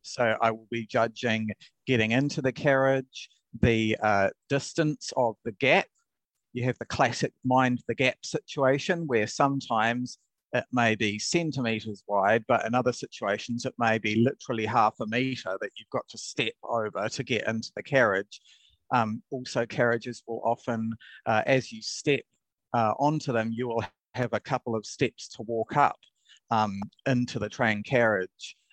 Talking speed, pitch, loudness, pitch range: 165 wpm, 120 Hz, -28 LUFS, 110-130 Hz